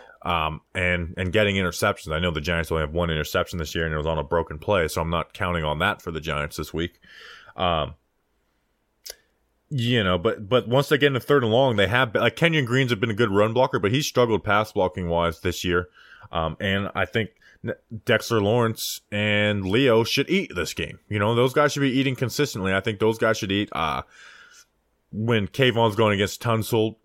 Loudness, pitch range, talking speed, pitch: -23 LUFS, 85-120 Hz, 215 wpm, 105 Hz